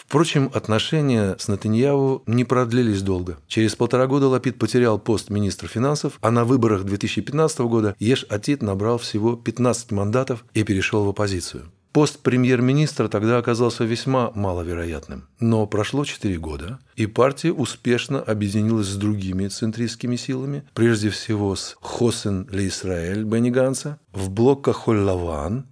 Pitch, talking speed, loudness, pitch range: 115 Hz, 135 wpm, -21 LUFS, 100-125 Hz